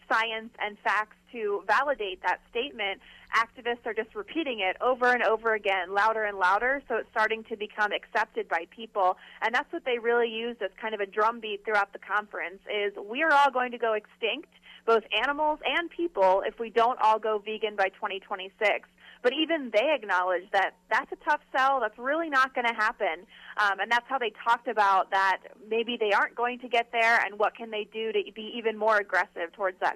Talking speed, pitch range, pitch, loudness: 205 wpm, 205-245 Hz, 220 Hz, -27 LUFS